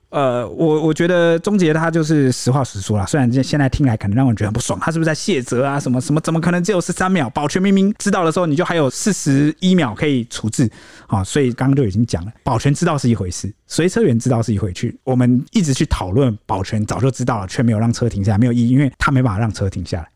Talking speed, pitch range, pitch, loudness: 410 characters per minute, 115-160 Hz, 135 Hz, -17 LUFS